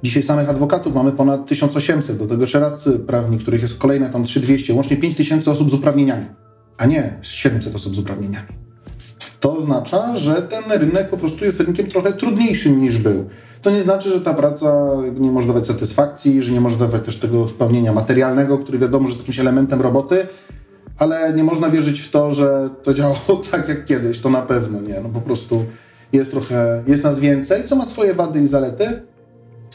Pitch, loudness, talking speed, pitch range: 135 Hz, -17 LUFS, 190 wpm, 120-150 Hz